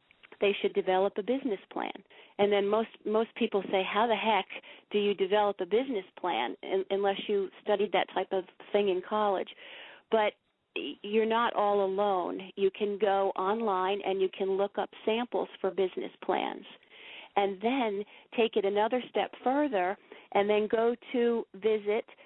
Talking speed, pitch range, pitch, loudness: 165 wpm, 195-225 Hz, 205 Hz, -30 LUFS